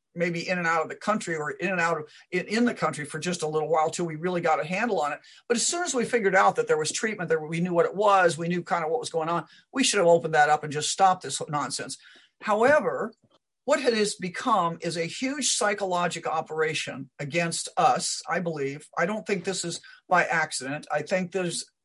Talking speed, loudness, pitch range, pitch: 245 wpm, -26 LUFS, 160-210 Hz, 175 Hz